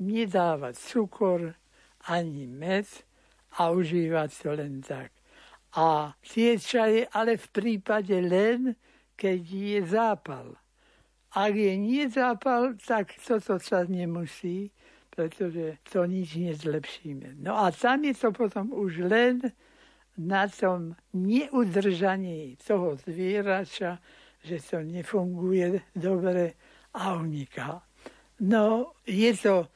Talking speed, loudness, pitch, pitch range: 105 wpm, -28 LUFS, 190 Hz, 170-220 Hz